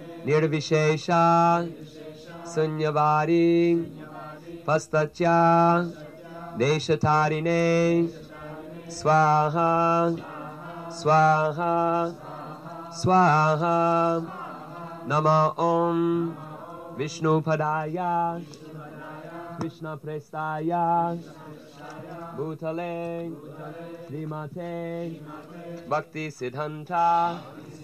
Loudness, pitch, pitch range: -24 LUFS, 160 Hz, 155-170 Hz